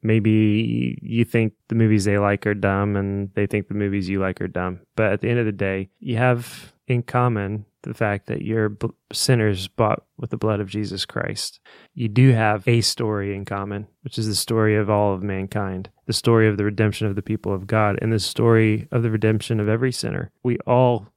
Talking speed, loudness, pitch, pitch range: 220 wpm, -22 LUFS, 105 Hz, 100-115 Hz